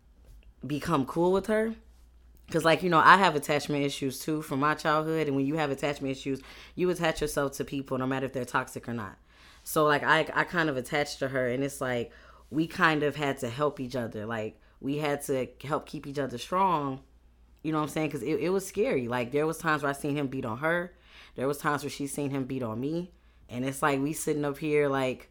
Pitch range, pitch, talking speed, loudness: 130-155 Hz, 145 Hz, 240 wpm, -29 LUFS